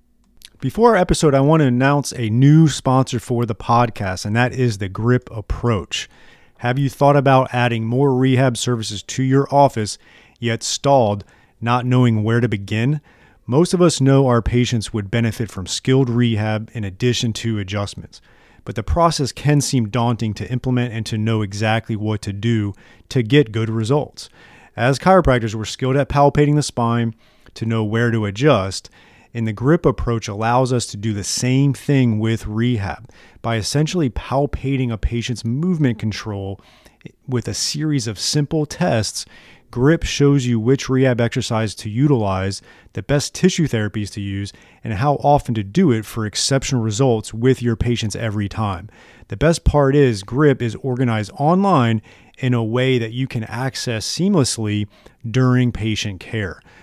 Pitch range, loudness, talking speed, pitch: 110-135 Hz, -18 LUFS, 165 wpm, 120 Hz